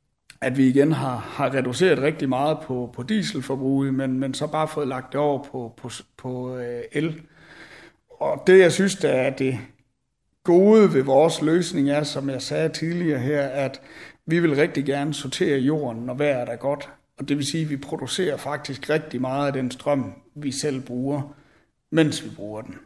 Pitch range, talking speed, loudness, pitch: 130-155 Hz, 175 wpm, -23 LUFS, 140 Hz